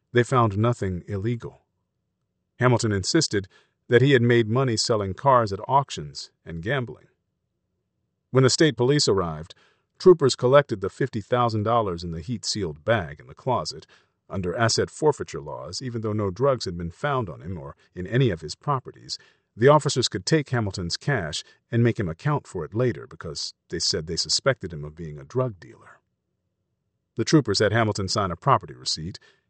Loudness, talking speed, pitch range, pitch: -23 LUFS, 175 wpm, 95-130 Hz, 115 Hz